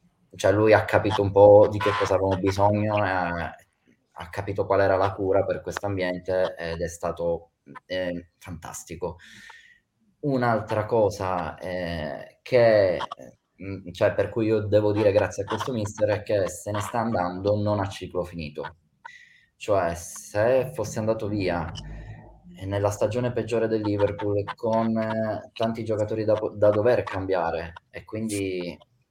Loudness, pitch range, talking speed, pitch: -24 LUFS, 95-110 Hz, 145 wpm, 105 Hz